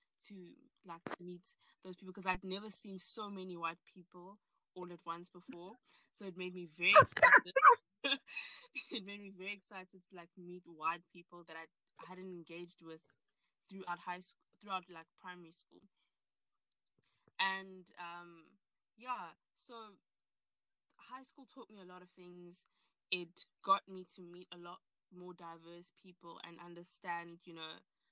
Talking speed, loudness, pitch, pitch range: 155 wpm, -35 LUFS, 180 Hz, 175-195 Hz